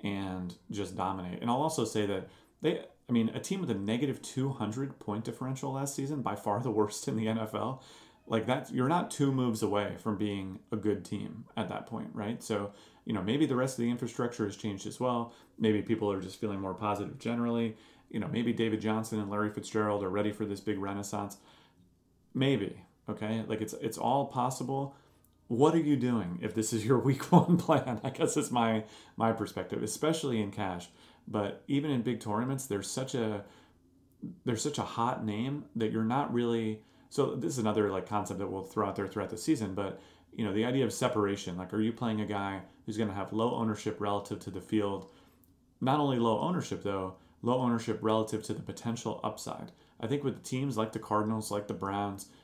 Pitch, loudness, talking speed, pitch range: 110 Hz, -33 LUFS, 210 wpm, 105-125 Hz